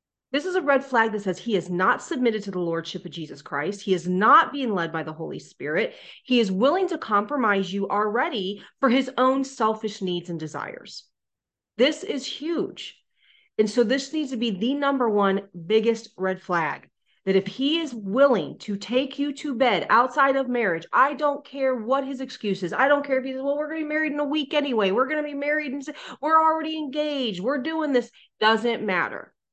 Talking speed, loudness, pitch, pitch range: 215 wpm, -24 LUFS, 250 Hz, 200-285 Hz